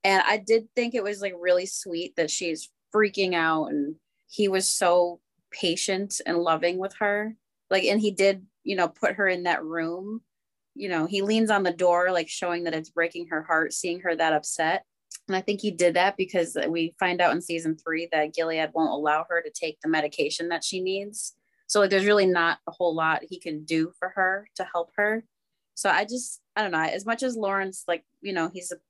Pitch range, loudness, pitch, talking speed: 165-200 Hz, -26 LUFS, 180 Hz, 220 wpm